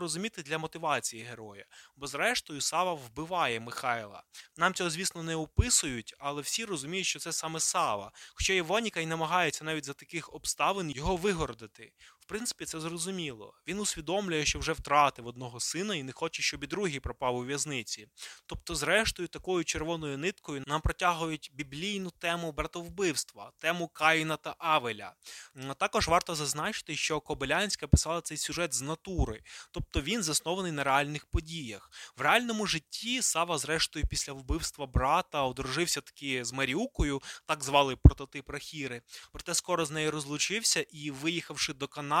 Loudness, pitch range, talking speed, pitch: -31 LUFS, 140-175 Hz, 150 wpm, 155 Hz